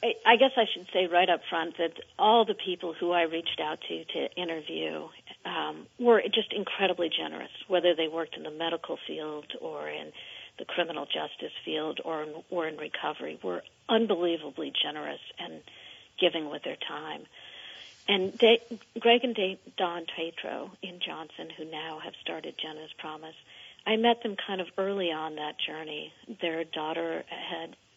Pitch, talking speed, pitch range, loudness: 170 Hz, 165 wpm, 155-200 Hz, -30 LUFS